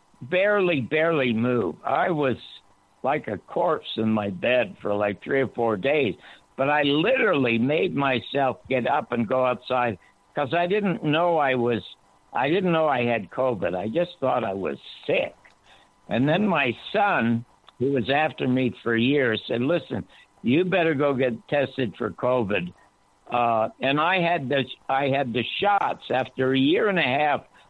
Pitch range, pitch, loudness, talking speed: 115-145 Hz, 130 Hz, -24 LUFS, 170 wpm